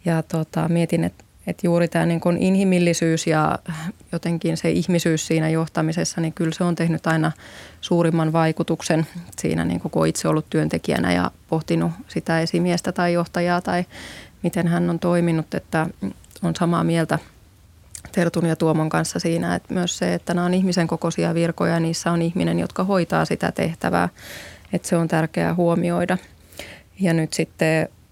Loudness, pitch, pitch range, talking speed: -22 LUFS, 165 Hz, 155-175 Hz, 160 wpm